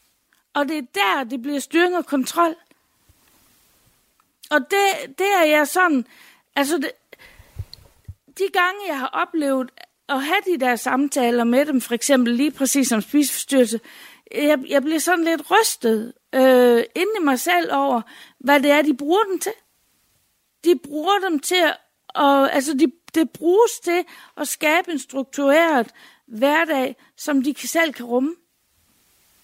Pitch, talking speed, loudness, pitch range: 295 Hz, 155 wpm, -19 LUFS, 265-335 Hz